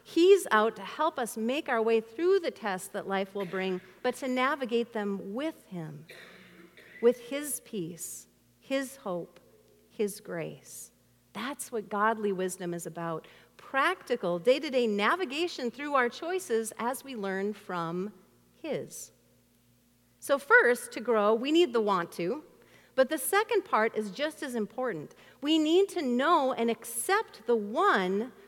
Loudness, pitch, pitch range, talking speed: -29 LUFS, 230 Hz, 195-280 Hz, 150 wpm